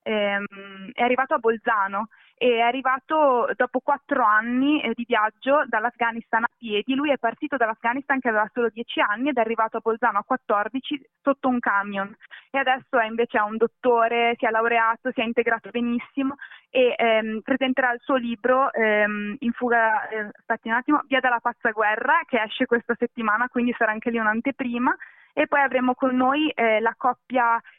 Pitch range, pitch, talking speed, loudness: 225-260 Hz, 235 Hz, 175 wpm, -23 LUFS